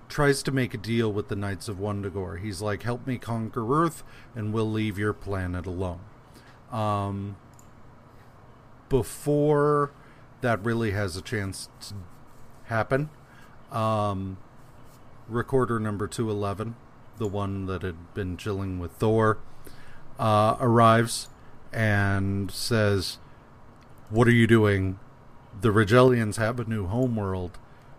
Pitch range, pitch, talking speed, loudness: 105-125 Hz, 115 Hz, 120 wpm, -26 LUFS